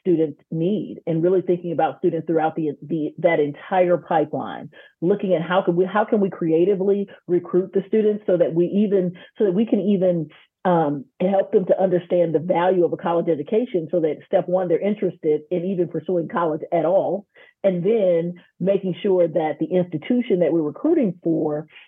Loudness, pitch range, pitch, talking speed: -21 LUFS, 165-195 Hz, 180 Hz, 185 wpm